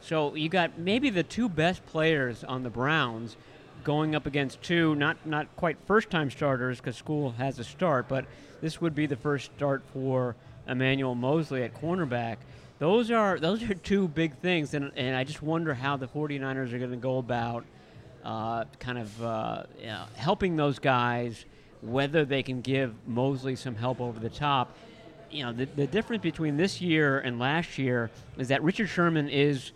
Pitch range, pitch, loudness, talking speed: 125-160 Hz, 140 Hz, -29 LUFS, 185 wpm